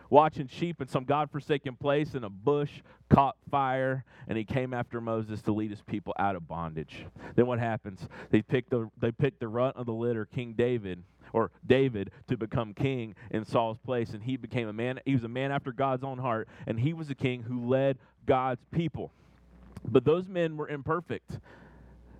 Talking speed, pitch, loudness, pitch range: 195 wpm, 125 Hz, -31 LUFS, 110-140 Hz